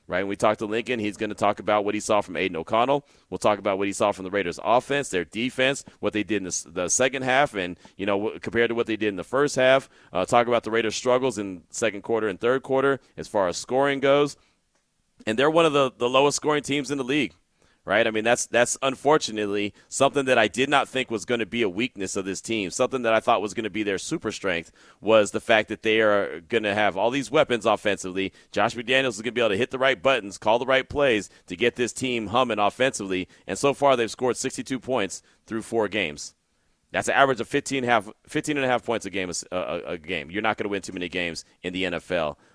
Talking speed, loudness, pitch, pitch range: 260 wpm, -24 LUFS, 115 Hz, 105-130 Hz